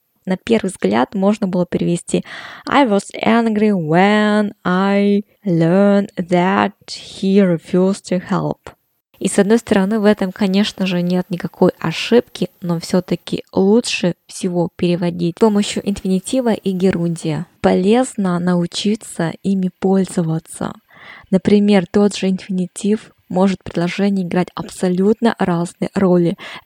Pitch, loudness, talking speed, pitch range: 190 Hz, -17 LUFS, 120 wpm, 180-205 Hz